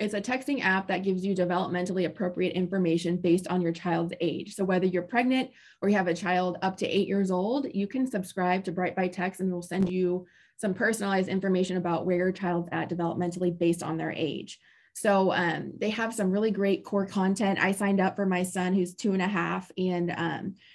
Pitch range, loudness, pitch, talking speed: 180-195 Hz, -28 LUFS, 185 Hz, 215 wpm